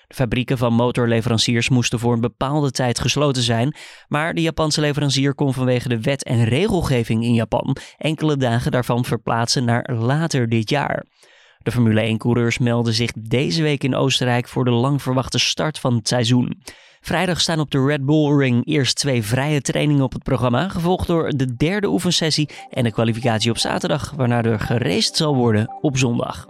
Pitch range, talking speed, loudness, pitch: 120-150 Hz, 180 wpm, -19 LUFS, 130 Hz